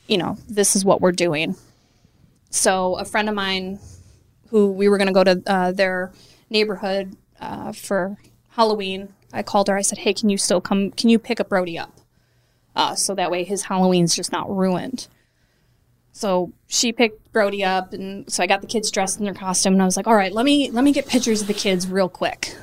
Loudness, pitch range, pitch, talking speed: -20 LUFS, 185-210 Hz, 195 Hz, 215 wpm